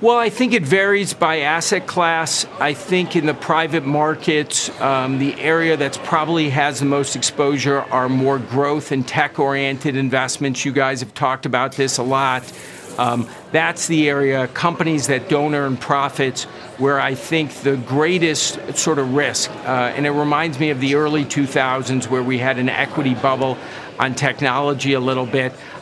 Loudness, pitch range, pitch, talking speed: -18 LUFS, 135-155 Hz, 140 Hz, 175 wpm